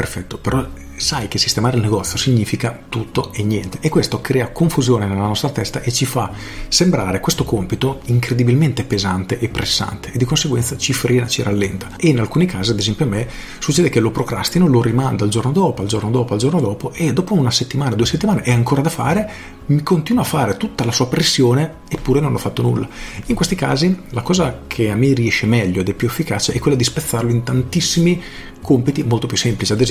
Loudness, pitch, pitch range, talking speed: -17 LUFS, 125 Hz, 110-145 Hz, 215 wpm